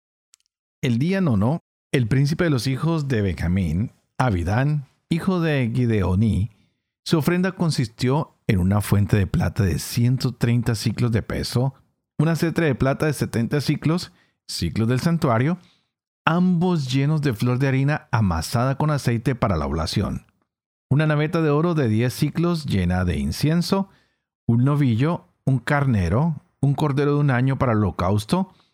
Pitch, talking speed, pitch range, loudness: 135 Hz, 150 wpm, 110-155 Hz, -22 LUFS